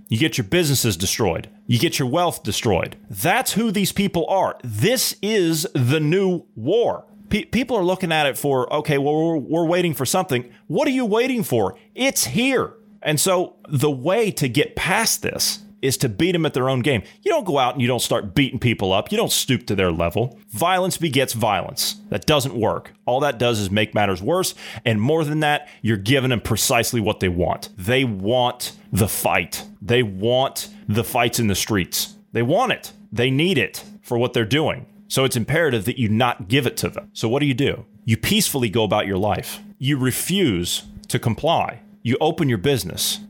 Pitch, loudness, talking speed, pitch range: 140 Hz, -20 LUFS, 205 wpm, 115-180 Hz